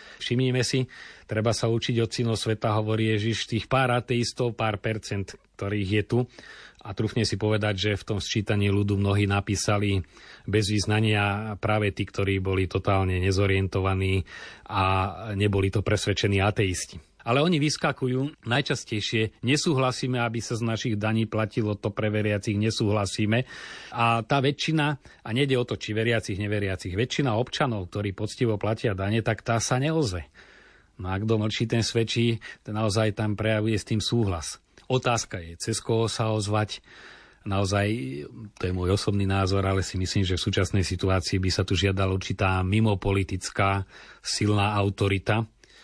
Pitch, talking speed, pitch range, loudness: 110 Hz, 150 wpm, 100-115 Hz, -26 LUFS